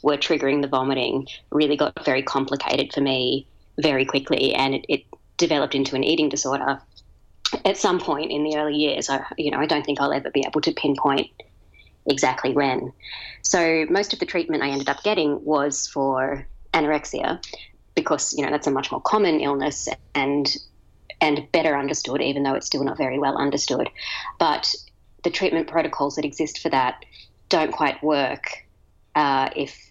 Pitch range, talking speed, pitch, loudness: 140-150 Hz, 175 wpm, 145 Hz, -23 LUFS